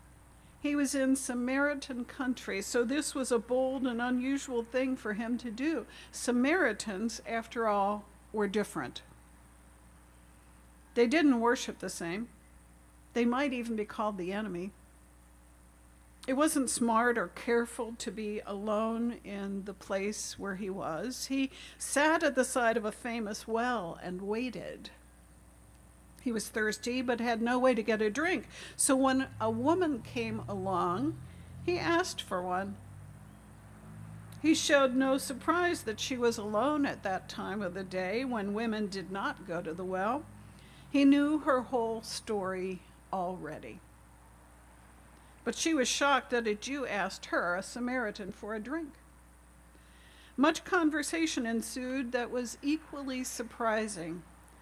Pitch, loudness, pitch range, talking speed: 225 Hz, -32 LUFS, 185-260 Hz, 140 wpm